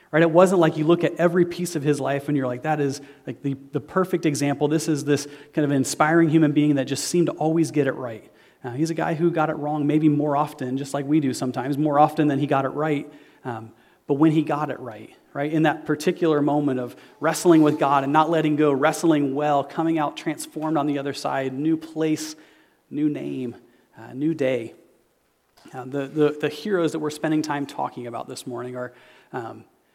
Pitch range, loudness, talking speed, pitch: 140-160 Hz, -22 LUFS, 225 wpm, 150 Hz